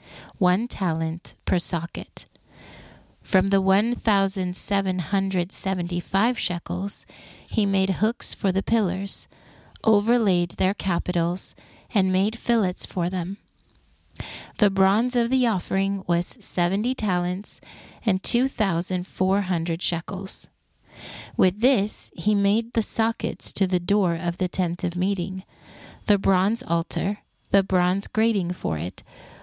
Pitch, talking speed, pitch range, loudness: 190 Hz, 130 wpm, 180-210 Hz, -23 LUFS